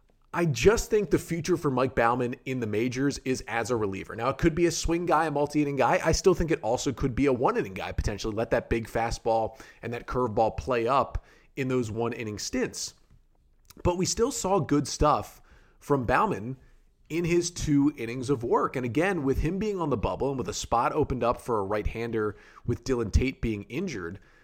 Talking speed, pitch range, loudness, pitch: 220 wpm, 115-155 Hz, -27 LUFS, 130 Hz